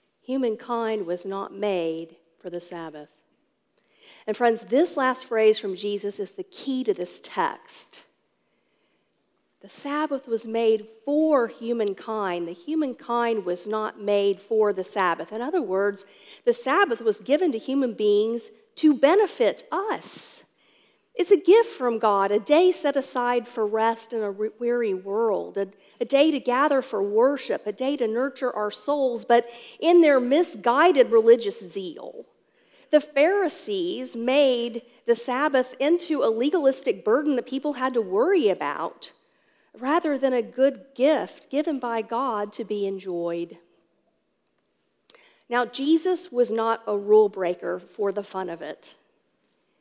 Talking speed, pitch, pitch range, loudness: 140 wpm, 245 Hz, 210-300 Hz, -24 LUFS